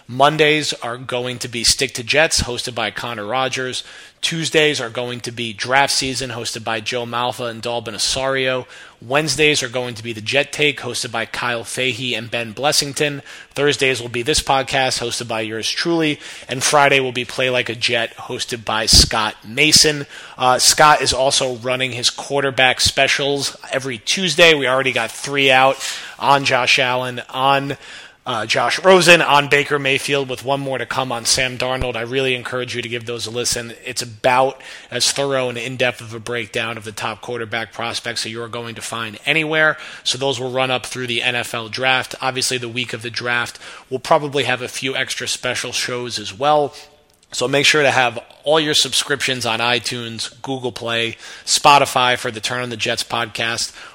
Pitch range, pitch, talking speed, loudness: 120-140 Hz, 125 Hz, 190 wpm, -17 LUFS